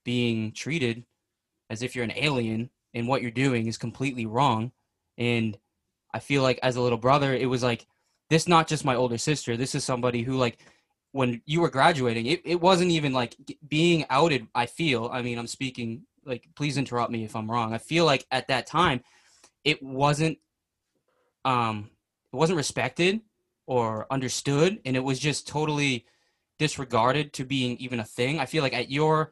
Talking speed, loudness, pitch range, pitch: 185 wpm, -26 LUFS, 120-150 Hz, 130 Hz